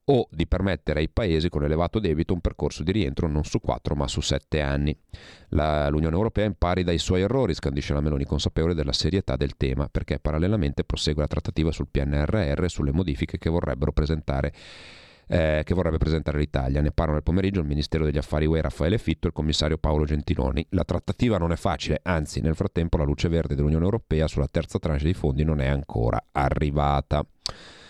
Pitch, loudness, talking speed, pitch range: 80 Hz, -25 LUFS, 190 wpm, 75-90 Hz